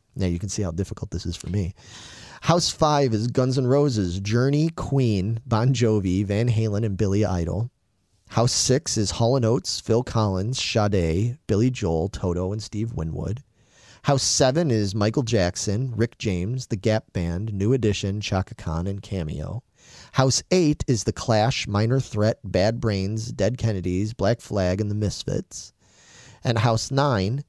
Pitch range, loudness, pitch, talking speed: 100-125 Hz, -23 LUFS, 110 Hz, 160 wpm